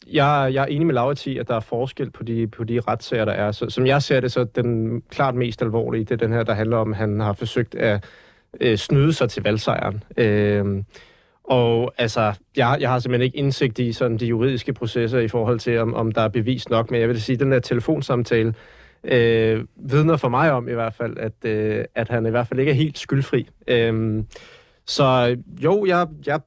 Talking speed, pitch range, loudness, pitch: 225 wpm, 115-135 Hz, -21 LUFS, 120 Hz